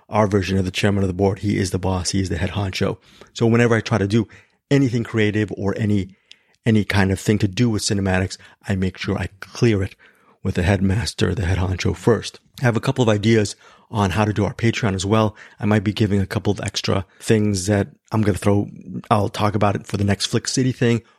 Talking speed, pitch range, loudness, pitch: 240 wpm, 95-110 Hz, -20 LUFS, 105 Hz